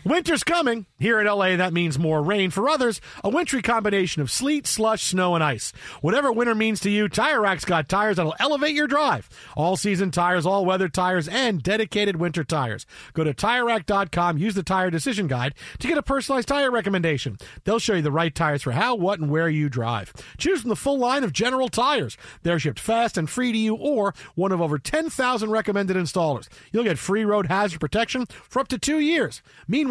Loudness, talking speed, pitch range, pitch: -23 LUFS, 210 wpm, 165-235 Hz, 200 Hz